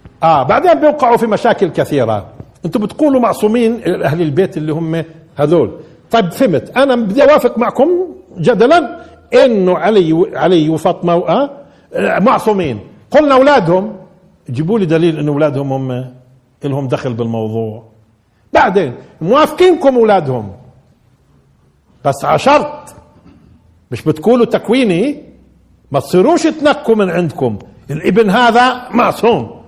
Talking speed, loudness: 110 wpm, -12 LUFS